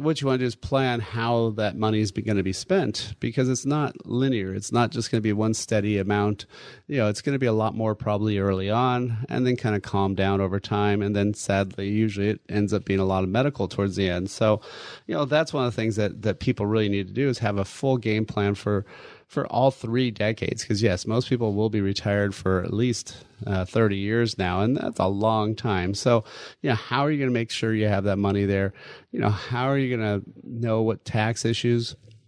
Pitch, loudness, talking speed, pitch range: 110 Hz, -25 LUFS, 250 wpm, 100-120 Hz